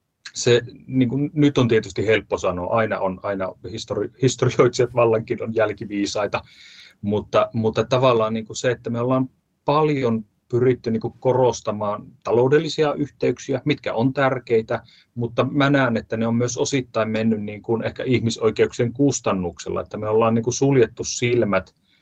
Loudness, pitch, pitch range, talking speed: -21 LUFS, 120 Hz, 110-130 Hz, 145 wpm